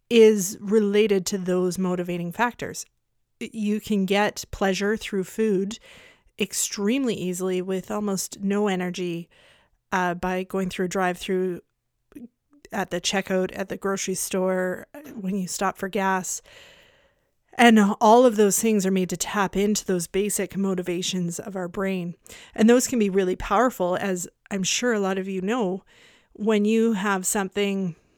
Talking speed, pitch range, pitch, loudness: 150 wpm, 185-215 Hz, 195 Hz, -24 LUFS